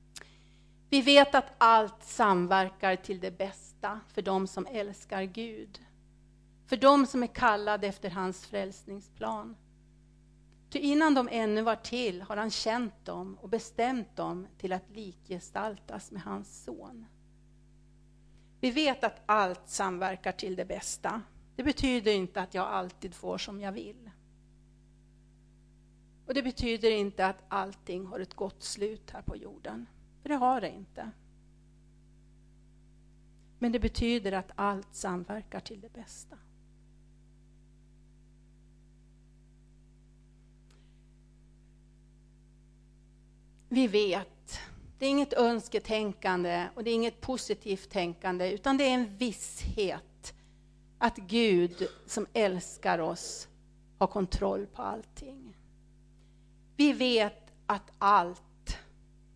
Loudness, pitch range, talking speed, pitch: -30 LUFS, 190-235 Hz, 115 wpm, 210 Hz